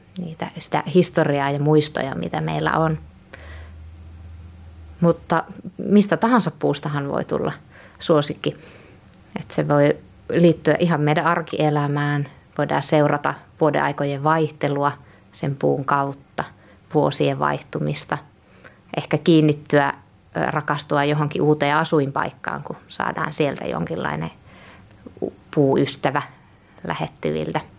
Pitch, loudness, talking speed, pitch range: 145 Hz, -21 LUFS, 95 wpm, 95-160 Hz